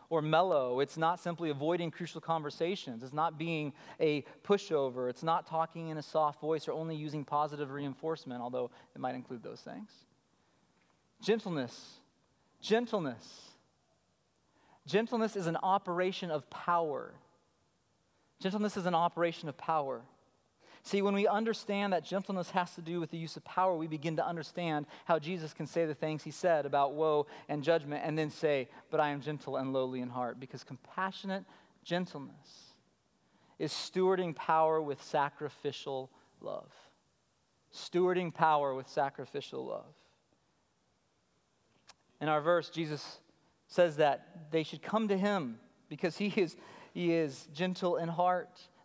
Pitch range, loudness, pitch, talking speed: 145-180 Hz, -34 LUFS, 160 Hz, 145 wpm